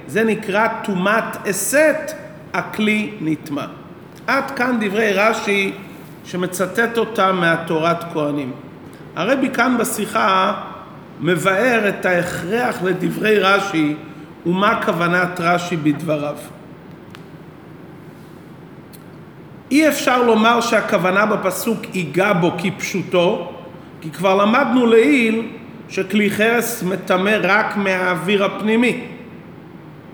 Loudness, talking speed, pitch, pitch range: -17 LUFS, 90 wpm, 195 Hz, 175-225 Hz